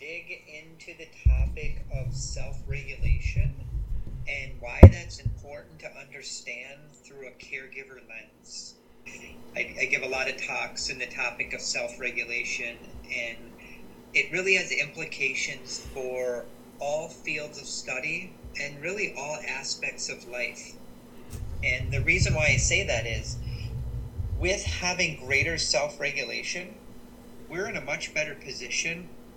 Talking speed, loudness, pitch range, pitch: 125 wpm, -28 LUFS, 105-140 Hz, 125 Hz